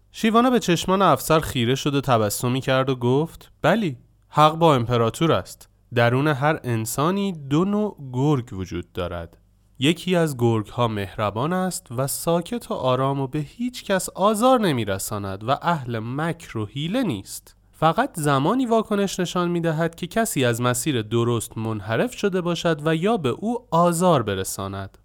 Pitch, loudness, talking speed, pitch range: 145 Hz, -22 LUFS, 160 wpm, 115-180 Hz